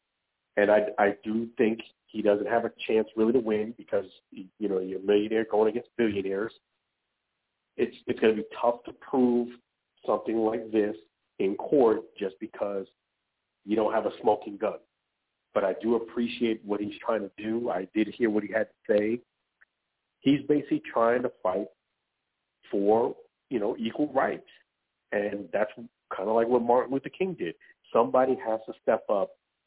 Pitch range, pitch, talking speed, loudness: 105-120 Hz, 110 Hz, 170 wpm, -28 LUFS